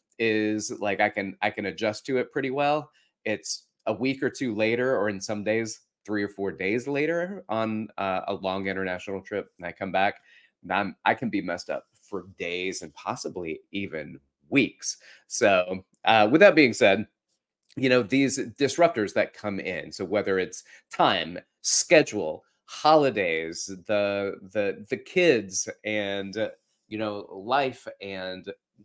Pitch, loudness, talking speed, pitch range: 105 Hz, -26 LUFS, 160 wpm, 95-115 Hz